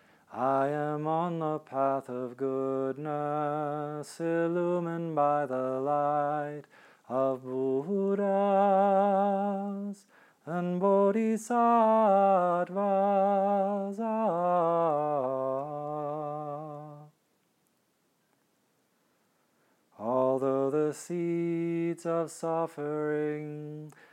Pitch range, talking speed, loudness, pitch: 145-195 Hz, 50 wpm, -29 LUFS, 155 Hz